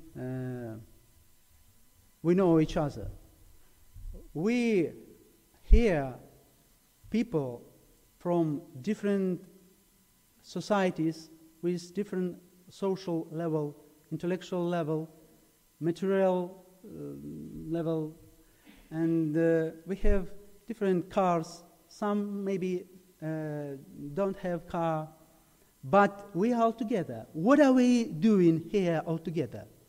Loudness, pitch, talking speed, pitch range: -30 LUFS, 170 Hz, 90 wpm, 155-190 Hz